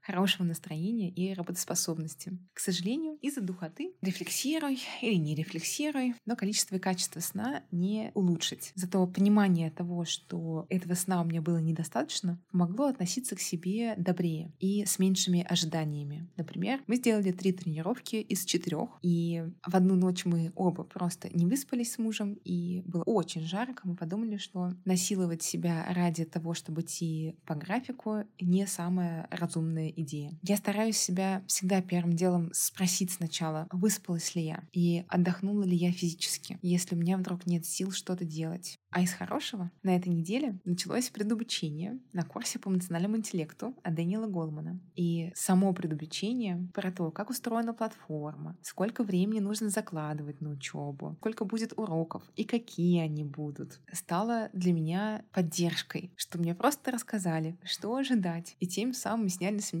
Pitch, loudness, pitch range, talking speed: 180 Hz, -32 LUFS, 170-210 Hz, 155 wpm